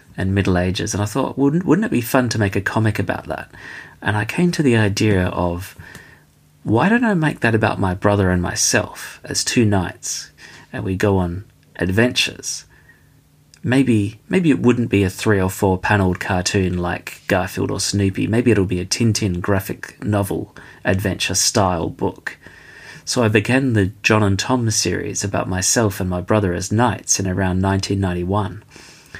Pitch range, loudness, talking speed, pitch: 95-115 Hz, -18 LUFS, 180 wpm, 100 Hz